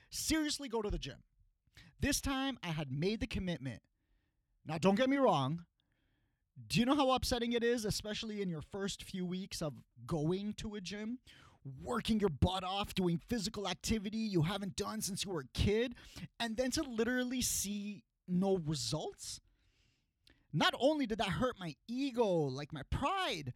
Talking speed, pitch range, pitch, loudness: 170 wpm, 165-235 Hz, 200 Hz, -36 LUFS